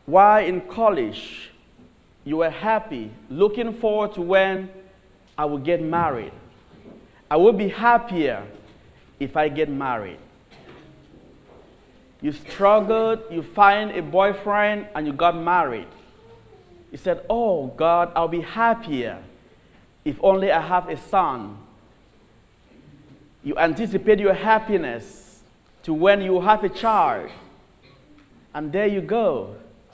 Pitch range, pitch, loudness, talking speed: 160-210 Hz, 190 Hz, -21 LUFS, 120 wpm